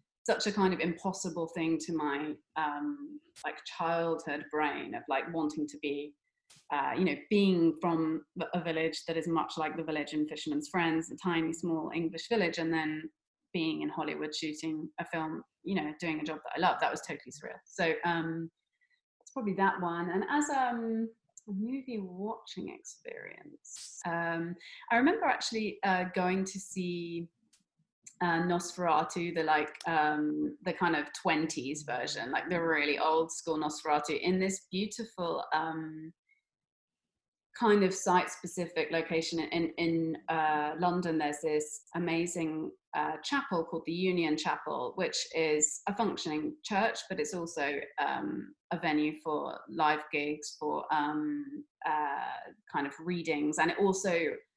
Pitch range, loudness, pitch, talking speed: 155-190 Hz, -33 LUFS, 165 Hz, 150 wpm